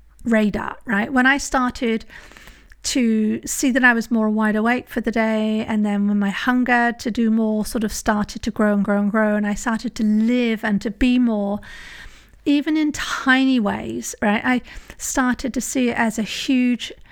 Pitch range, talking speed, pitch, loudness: 215-250 Hz, 195 wpm, 230 Hz, -20 LUFS